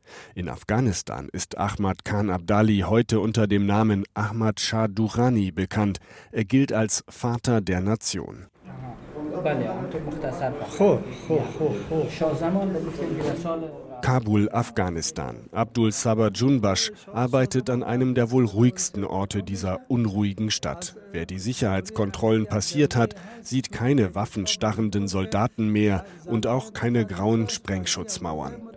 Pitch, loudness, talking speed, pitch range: 110 Hz, -25 LUFS, 105 wpm, 100-125 Hz